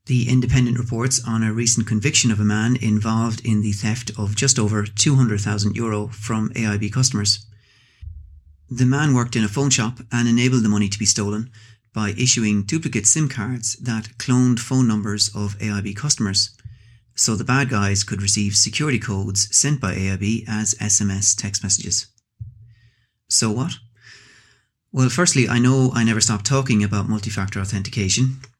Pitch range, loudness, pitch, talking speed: 105-125 Hz, -19 LUFS, 110 Hz, 160 wpm